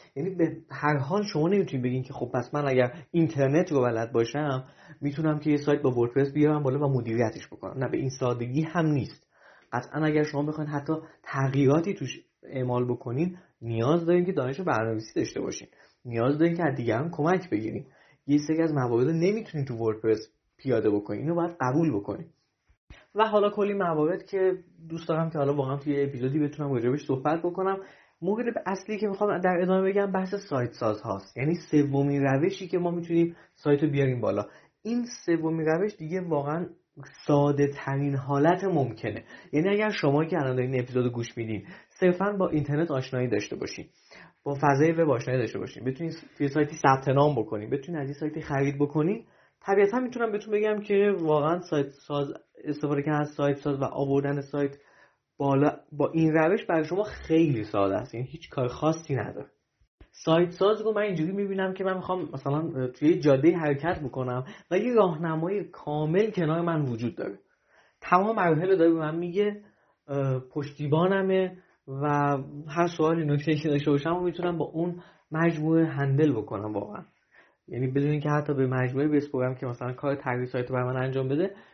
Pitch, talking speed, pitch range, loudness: 150 Hz, 175 wpm, 135-170 Hz, -27 LUFS